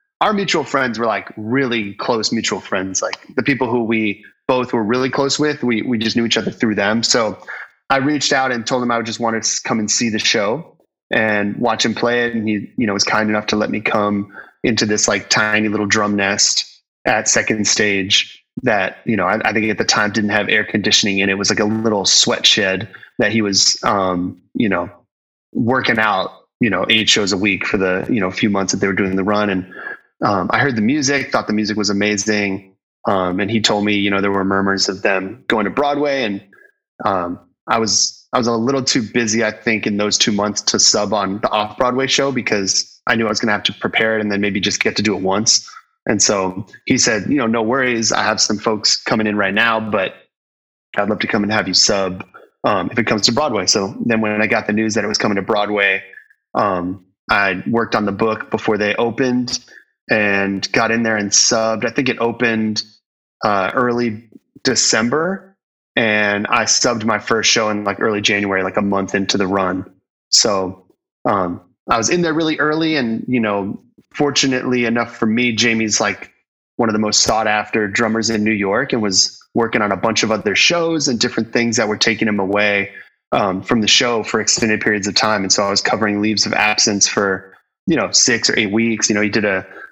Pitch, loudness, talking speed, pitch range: 110 Hz, -16 LUFS, 225 wpm, 100-115 Hz